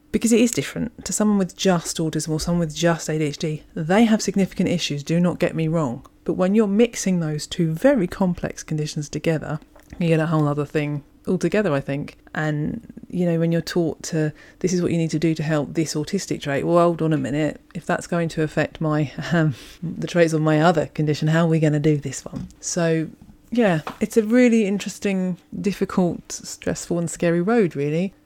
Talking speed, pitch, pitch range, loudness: 210 wpm, 170 Hz, 155-195 Hz, -22 LUFS